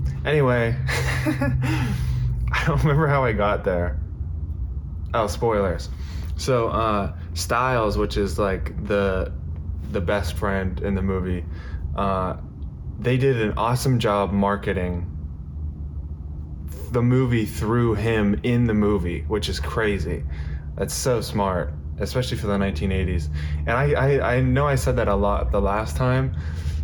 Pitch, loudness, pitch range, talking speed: 90 Hz, -23 LUFS, 75-105 Hz, 135 wpm